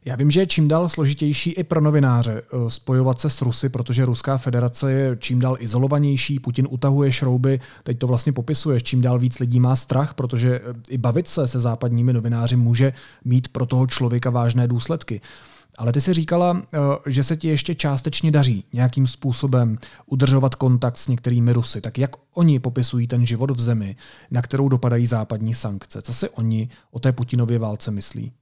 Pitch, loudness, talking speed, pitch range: 125 Hz, -20 LUFS, 180 wpm, 120-140 Hz